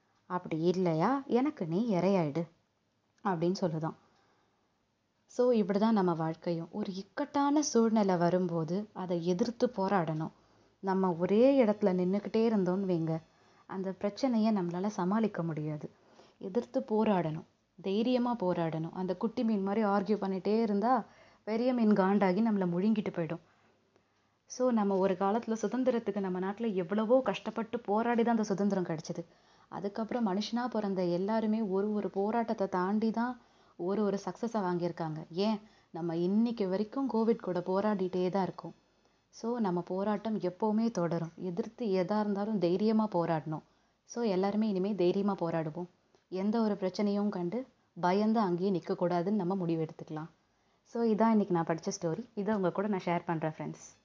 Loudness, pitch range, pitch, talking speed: -32 LUFS, 175-220 Hz, 195 Hz, 135 wpm